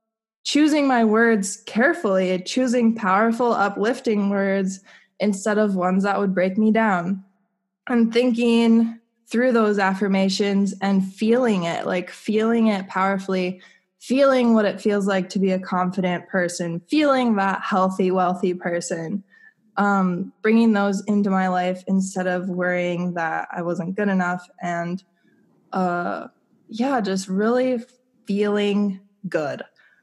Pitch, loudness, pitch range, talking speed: 200 Hz, -21 LUFS, 185-225 Hz, 130 wpm